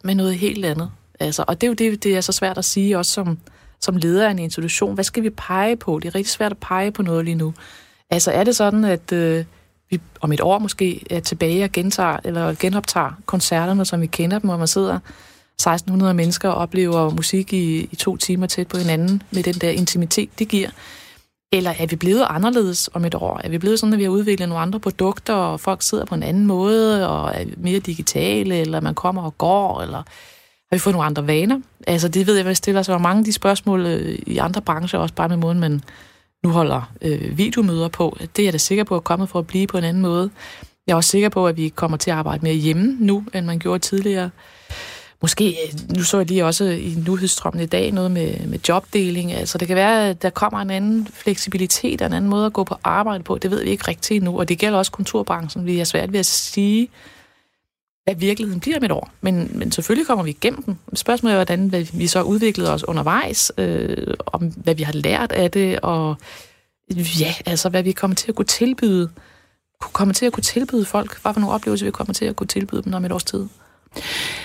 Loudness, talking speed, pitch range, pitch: -19 LUFS, 235 wpm, 170-200 Hz, 185 Hz